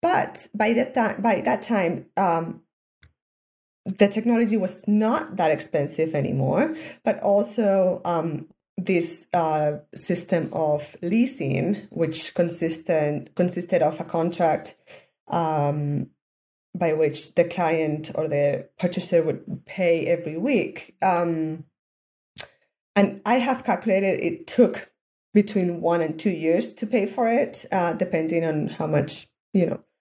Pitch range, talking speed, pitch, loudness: 155-200 Hz, 125 wpm, 170 Hz, -23 LUFS